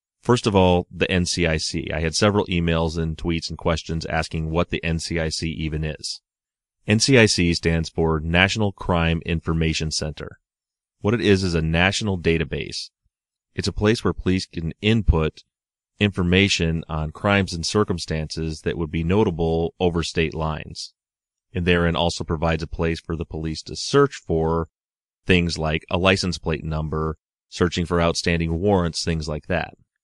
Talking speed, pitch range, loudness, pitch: 155 wpm, 80-95 Hz, -22 LUFS, 85 Hz